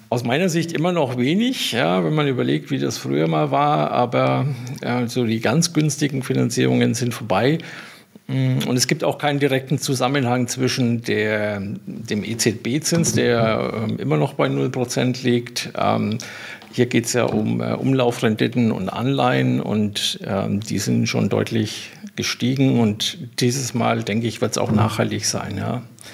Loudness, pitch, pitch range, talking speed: -20 LUFS, 120 Hz, 110-135 Hz, 150 wpm